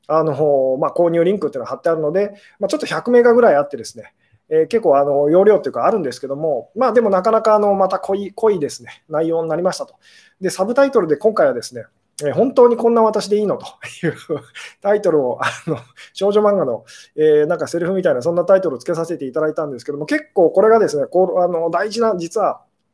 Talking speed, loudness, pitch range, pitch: 470 characters per minute, -17 LUFS, 165-225 Hz, 190 Hz